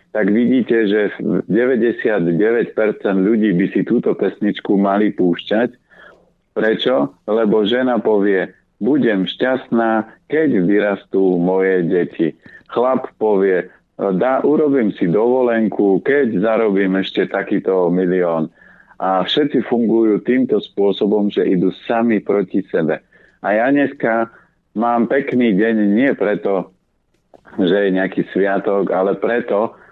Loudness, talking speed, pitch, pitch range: -17 LUFS, 110 wpm, 105 Hz, 95-120 Hz